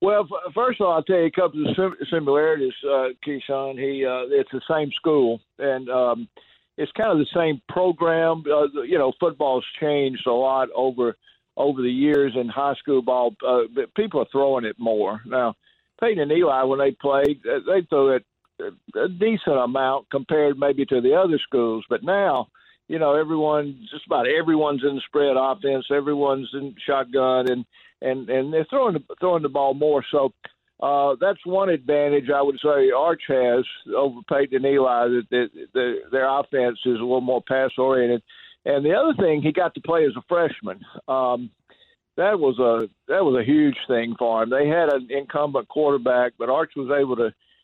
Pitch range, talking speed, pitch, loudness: 130-160 Hz, 185 wpm, 140 Hz, -22 LUFS